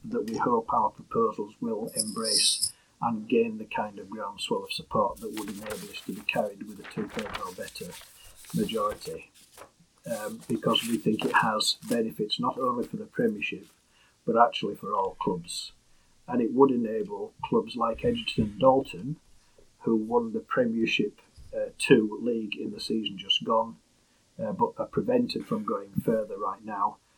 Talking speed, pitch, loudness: 165 wpm, 230 Hz, -28 LUFS